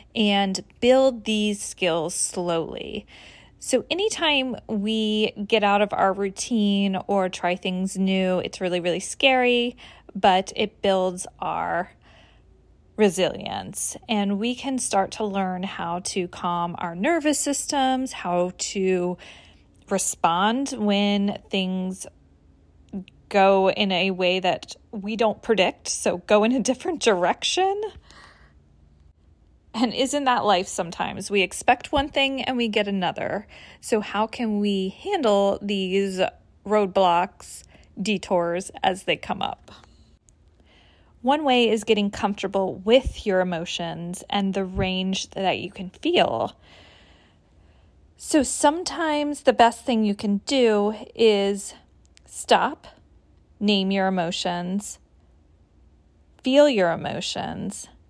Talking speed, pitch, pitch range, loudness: 115 wpm, 200 Hz, 180-230 Hz, -23 LUFS